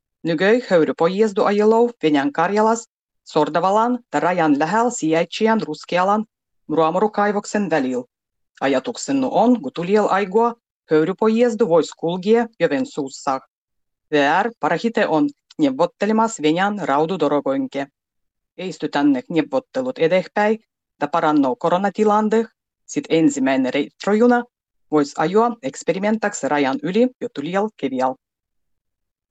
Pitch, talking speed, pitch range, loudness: 190 Hz, 100 wpm, 150-225 Hz, -19 LUFS